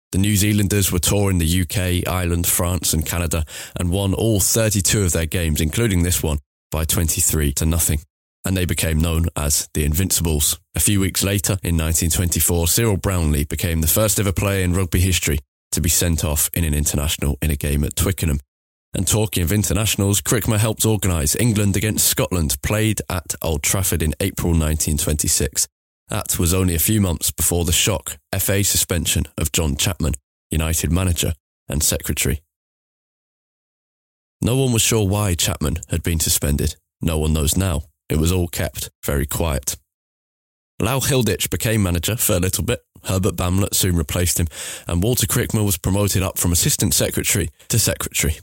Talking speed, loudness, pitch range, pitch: 170 wpm, -19 LUFS, 80-100 Hz, 90 Hz